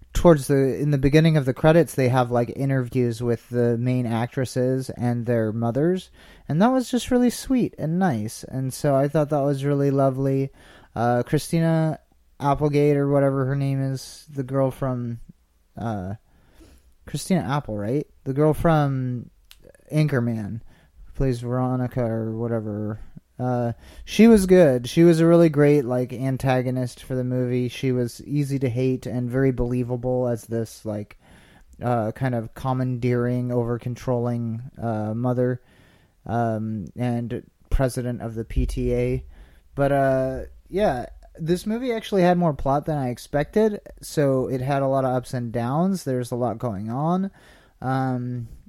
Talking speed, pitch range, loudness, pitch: 155 wpm, 120-145 Hz, -23 LUFS, 130 Hz